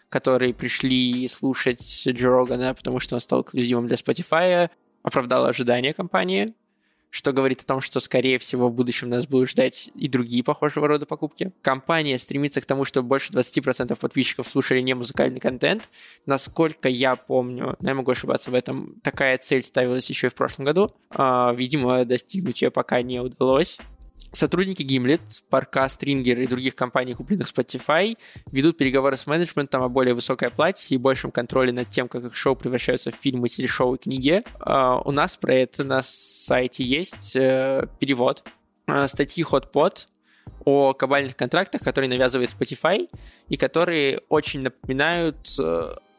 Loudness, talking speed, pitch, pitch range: -23 LUFS, 150 wpm, 130 Hz, 125-140 Hz